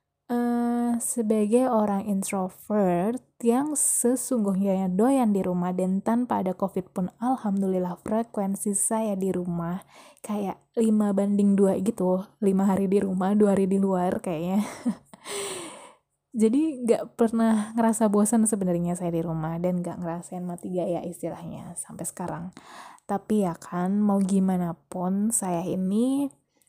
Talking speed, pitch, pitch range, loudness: 135 wpm, 200 Hz, 180-225 Hz, -25 LUFS